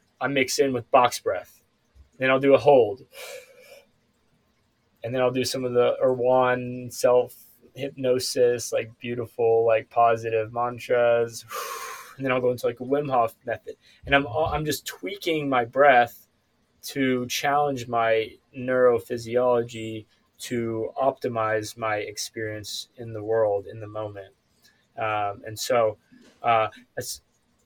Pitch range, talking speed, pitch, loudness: 115-130 Hz, 135 wpm, 120 Hz, -24 LUFS